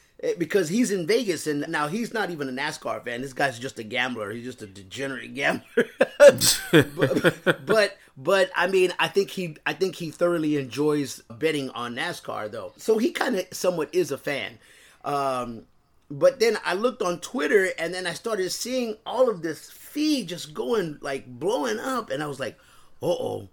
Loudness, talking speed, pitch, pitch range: -25 LUFS, 185 wpm, 170 Hz, 140-205 Hz